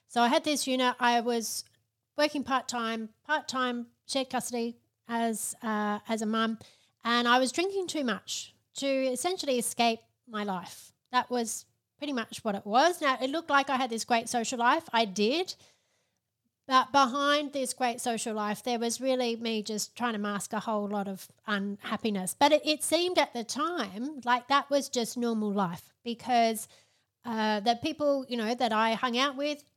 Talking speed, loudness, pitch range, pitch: 185 wpm, -29 LUFS, 220-270 Hz, 240 Hz